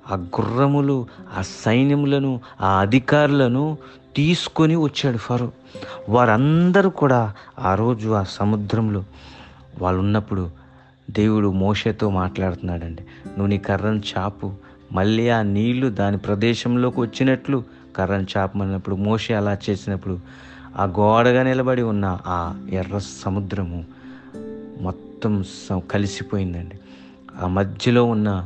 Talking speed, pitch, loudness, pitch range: 105 wpm, 105 Hz, -21 LUFS, 95-125 Hz